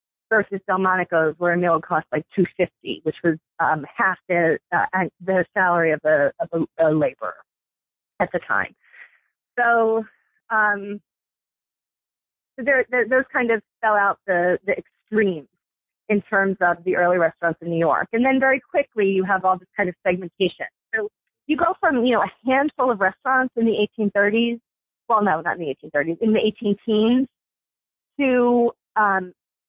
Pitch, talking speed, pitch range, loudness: 200 Hz, 175 wpm, 175-235 Hz, -21 LUFS